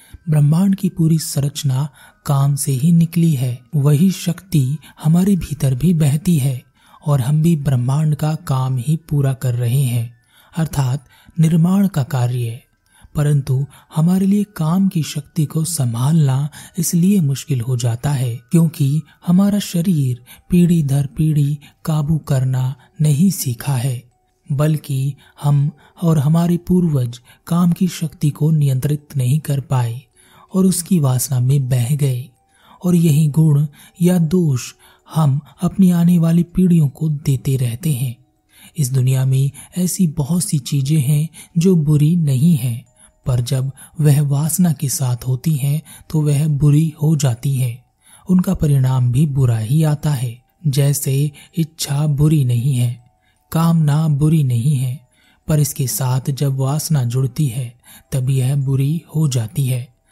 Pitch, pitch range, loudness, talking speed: 145 Hz, 130-160 Hz, -17 LUFS, 145 wpm